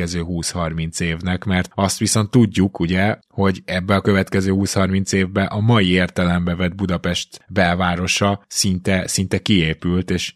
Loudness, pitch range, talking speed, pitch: -19 LUFS, 90-100 Hz, 135 wpm, 95 Hz